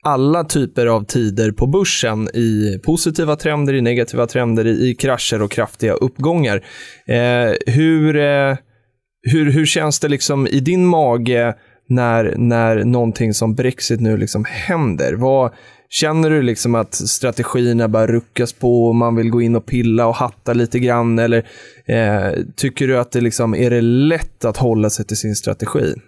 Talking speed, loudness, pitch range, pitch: 165 wpm, -16 LUFS, 115-135 Hz, 120 Hz